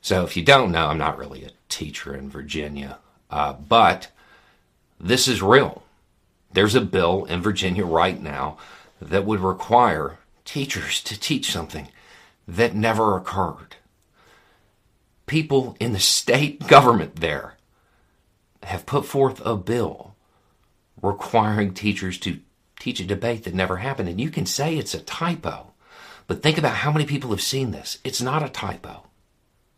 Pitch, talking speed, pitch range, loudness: 105 Hz, 150 wpm, 95-130 Hz, -21 LUFS